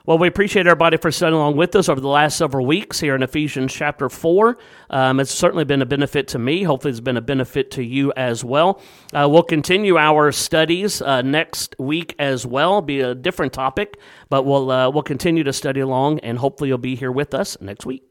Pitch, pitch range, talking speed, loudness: 145 Hz, 130-165 Hz, 220 wpm, -18 LUFS